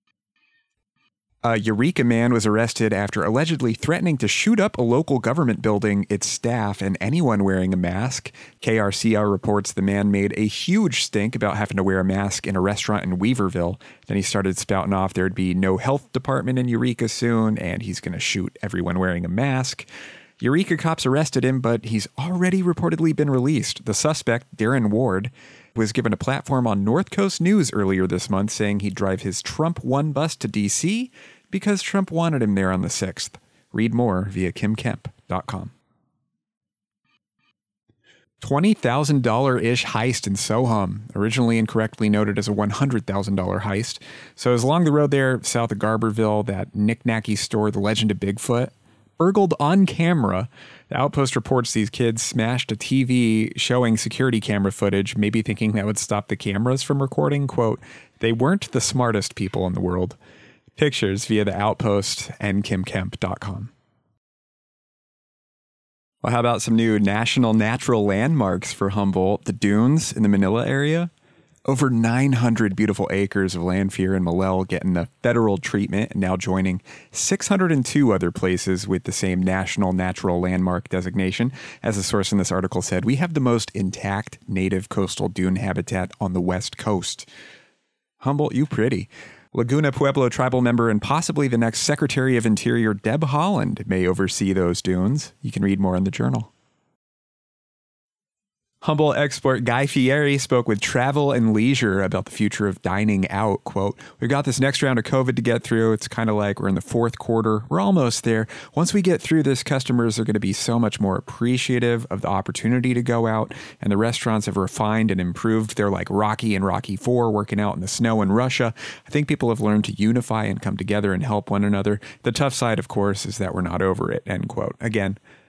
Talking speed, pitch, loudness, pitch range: 180 wpm, 110 Hz, -22 LUFS, 100-130 Hz